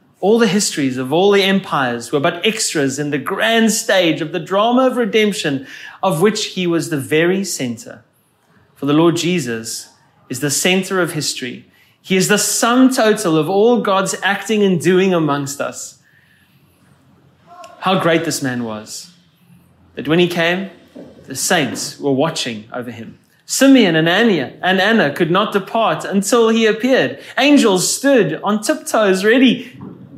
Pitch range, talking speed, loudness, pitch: 155-215 Hz, 155 wpm, -15 LUFS, 185 Hz